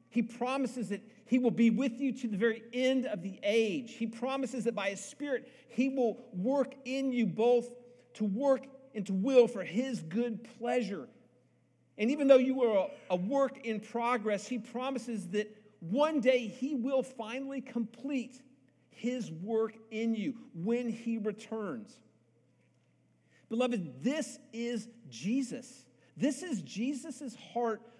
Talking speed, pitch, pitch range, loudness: 150 wpm, 235 Hz, 220-260 Hz, -33 LUFS